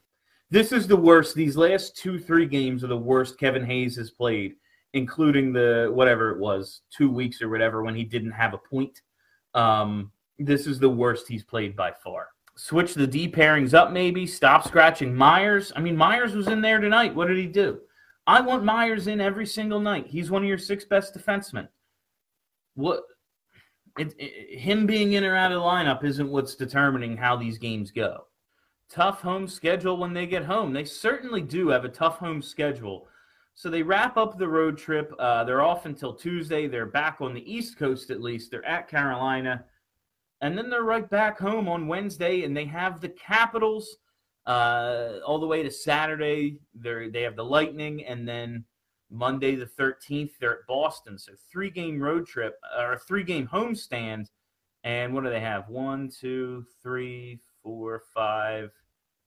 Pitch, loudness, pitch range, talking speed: 145 Hz, -24 LUFS, 120-185 Hz, 185 wpm